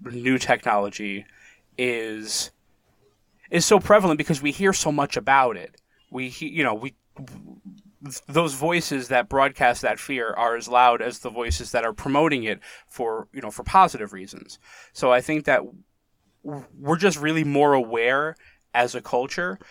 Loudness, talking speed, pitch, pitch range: -22 LUFS, 160 wpm, 135 Hz, 115-155 Hz